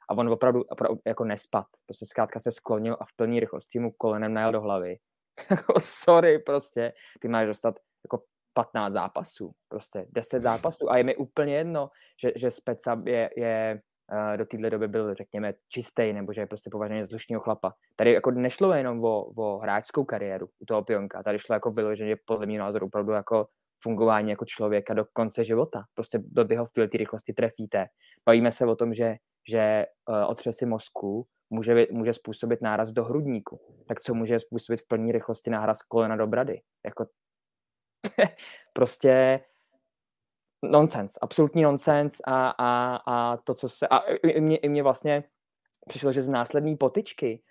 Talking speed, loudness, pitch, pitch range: 170 wpm, -27 LUFS, 115 Hz, 110-130 Hz